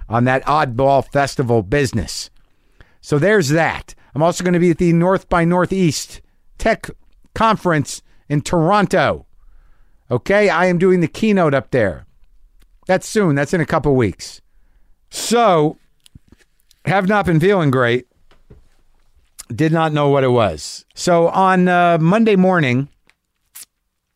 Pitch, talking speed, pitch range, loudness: 155 Hz, 135 wpm, 125-180 Hz, -16 LUFS